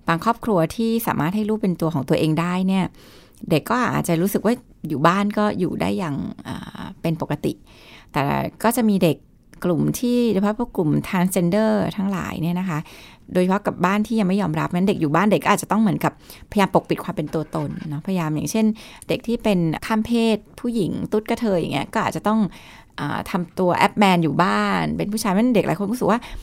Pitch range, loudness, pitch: 165-215 Hz, -21 LUFS, 190 Hz